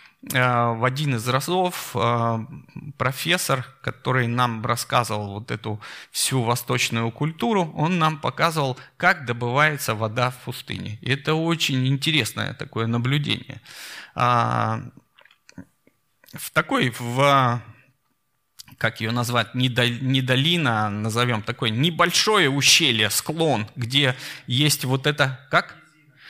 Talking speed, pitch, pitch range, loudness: 105 wpm, 130 Hz, 120-150 Hz, -22 LUFS